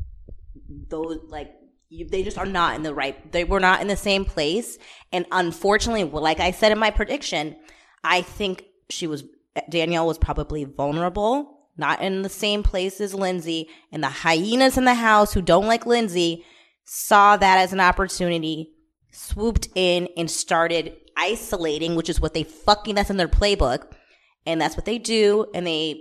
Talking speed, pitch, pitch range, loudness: 175 wpm, 180 Hz, 160-205 Hz, -21 LUFS